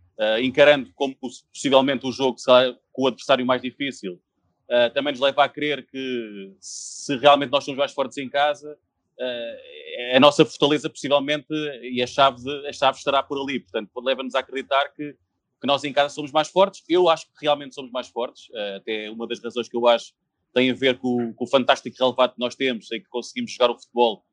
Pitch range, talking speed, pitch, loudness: 120-145 Hz, 210 wpm, 135 Hz, -22 LUFS